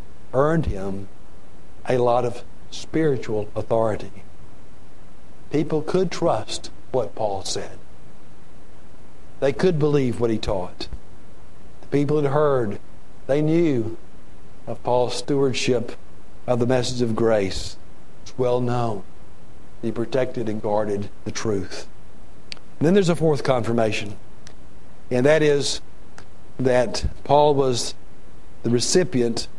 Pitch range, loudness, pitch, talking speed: 105-140 Hz, -22 LUFS, 120 Hz, 115 wpm